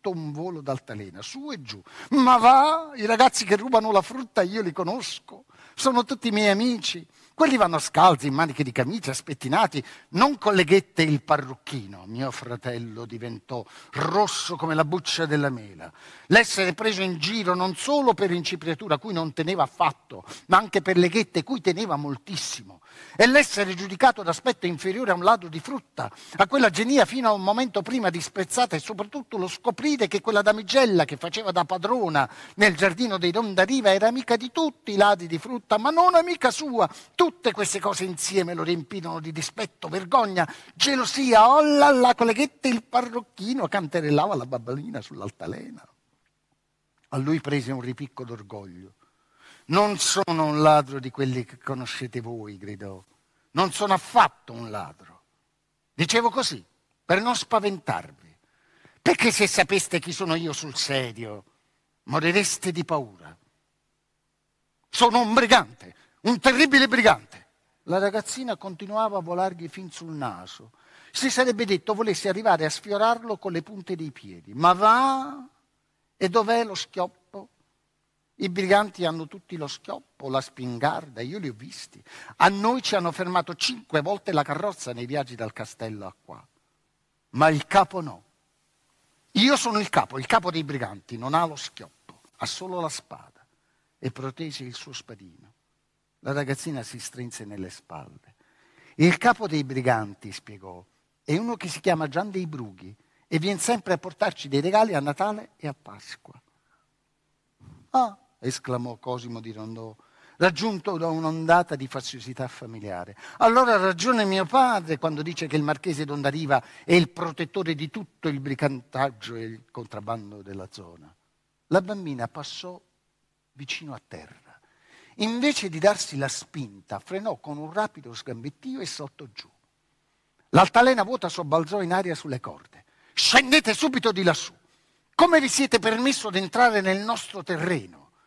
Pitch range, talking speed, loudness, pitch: 140-215 Hz, 155 wpm, -23 LUFS, 175 Hz